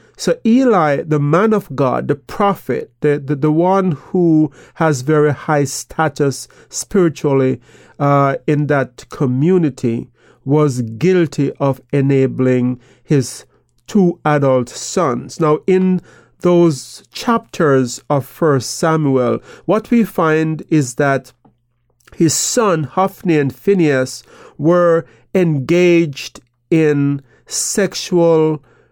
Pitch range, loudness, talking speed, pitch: 135-170 Hz, -15 LUFS, 105 wpm, 150 Hz